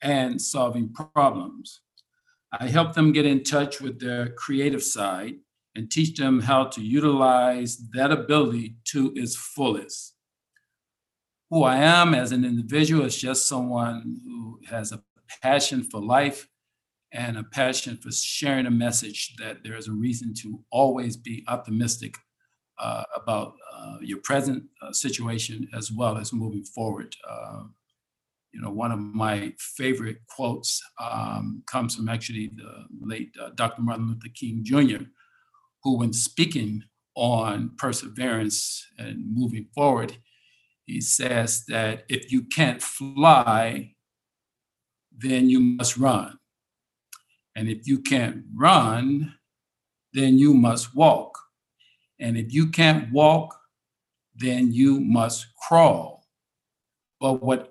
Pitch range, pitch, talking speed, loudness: 115-140 Hz, 125 Hz, 130 wpm, -23 LUFS